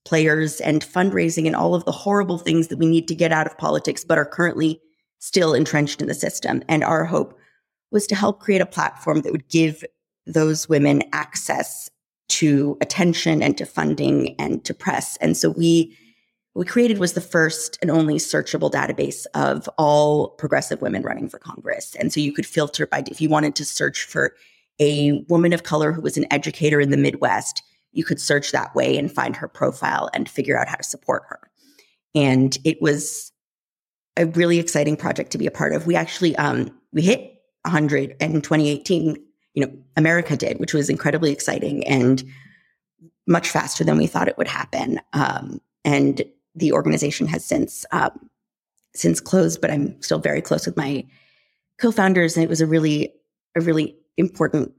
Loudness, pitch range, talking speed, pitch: -21 LUFS, 150-170 Hz, 185 wpm, 155 Hz